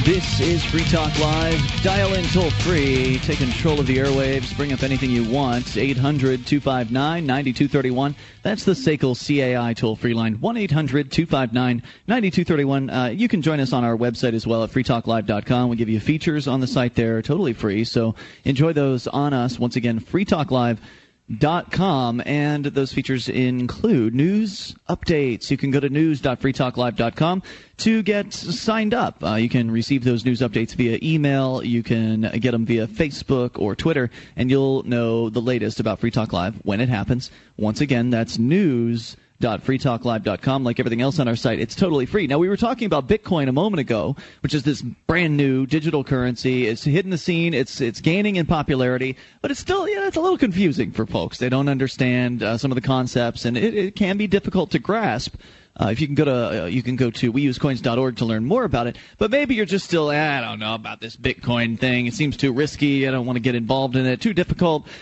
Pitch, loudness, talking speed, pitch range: 130 Hz, -21 LUFS, 205 wpm, 120-155 Hz